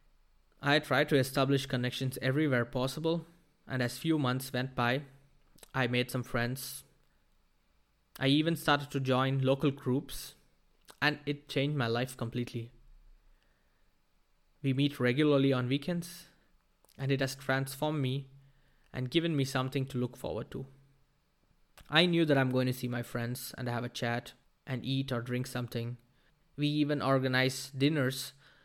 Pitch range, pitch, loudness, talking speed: 125-145 Hz, 135 Hz, -32 LUFS, 145 wpm